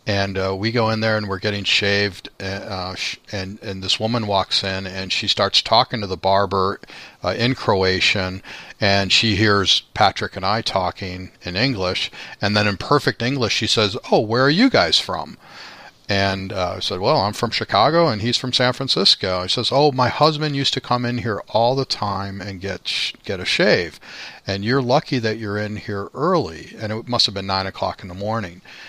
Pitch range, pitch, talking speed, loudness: 95-120 Hz, 100 Hz, 210 wpm, -19 LUFS